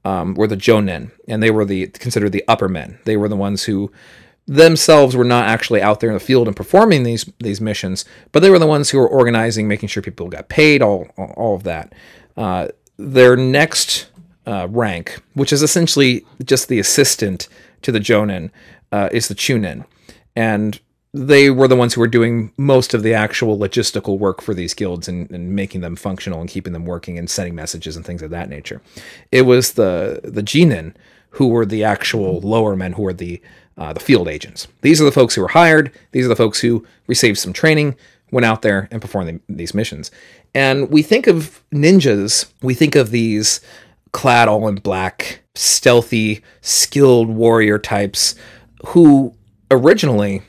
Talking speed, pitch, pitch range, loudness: 190 wpm, 110 Hz, 100-130 Hz, -14 LUFS